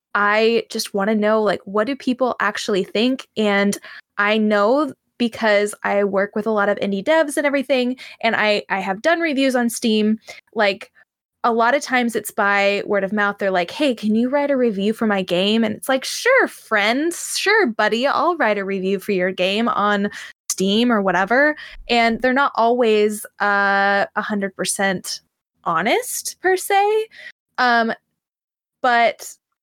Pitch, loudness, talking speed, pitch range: 220 Hz, -19 LUFS, 170 wpm, 205-270 Hz